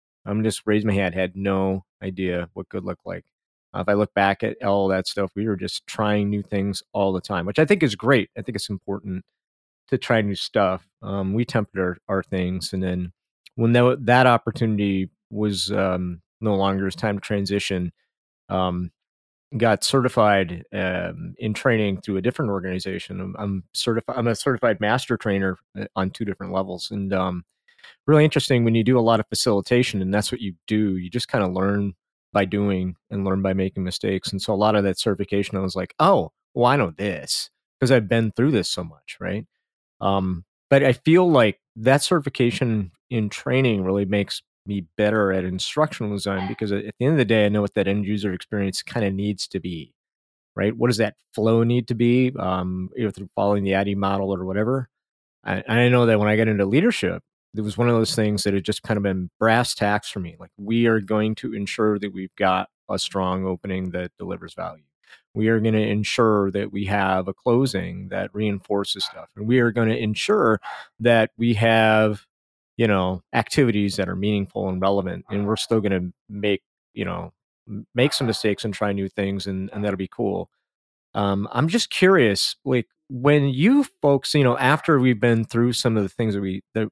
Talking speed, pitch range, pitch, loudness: 210 wpm, 95-115 Hz, 105 Hz, -22 LUFS